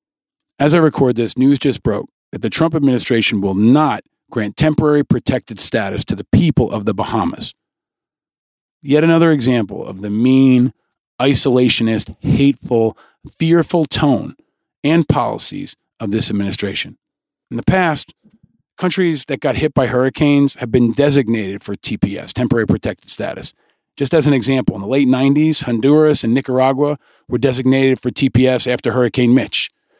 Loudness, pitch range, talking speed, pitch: -15 LUFS, 120-145 Hz, 145 wpm, 130 Hz